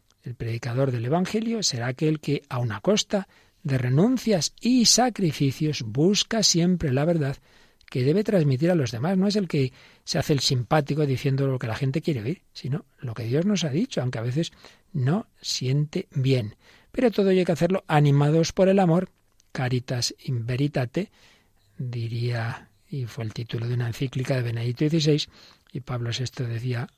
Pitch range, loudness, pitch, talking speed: 125-175 Hz, -24 LUFS, 145 Hz, 175 wpm